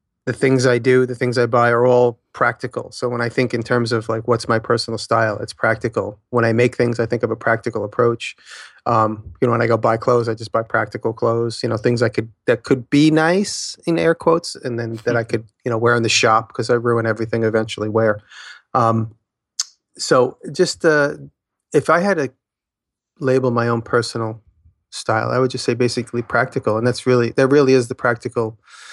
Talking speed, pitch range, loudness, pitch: 220 wpm, 115-125 Hz, -18 LUFS, 120 Hz